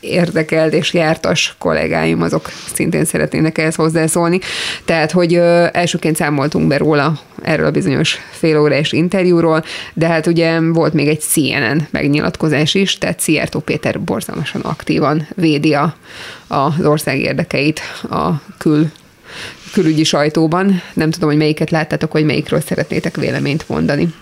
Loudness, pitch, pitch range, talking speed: -15 LUFS, 160 Hz, 150-170 Hz, 135 wpm